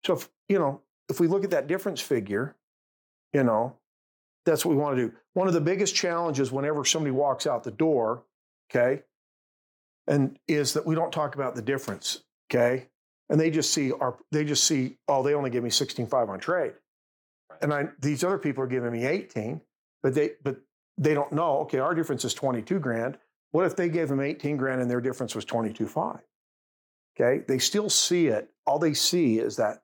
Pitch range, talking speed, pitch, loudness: 125-160 Hz, 210 wpm, 140 Hz, -27 LUFS